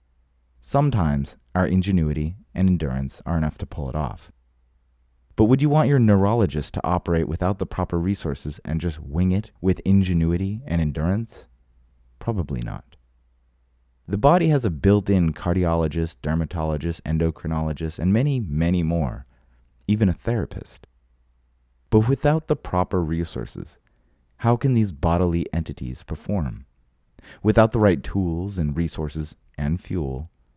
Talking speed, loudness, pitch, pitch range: 130 wpm, -23 LUFS, 80 Hz, 65-95 Hz